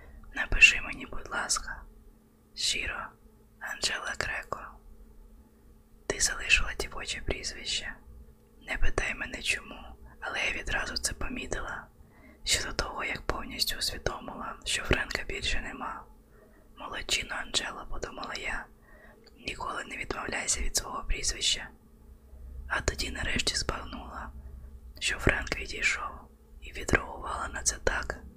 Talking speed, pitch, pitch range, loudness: 110 wpm, 70 Hz, 65-75 Hz, -30 LUFS